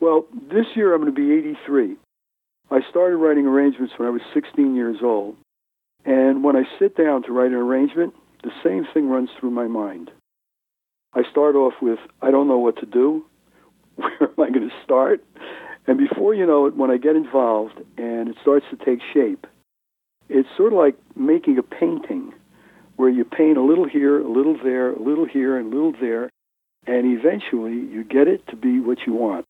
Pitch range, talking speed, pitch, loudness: 125-180 Hz, 200 wpm, 140 Hz, -19 LUFS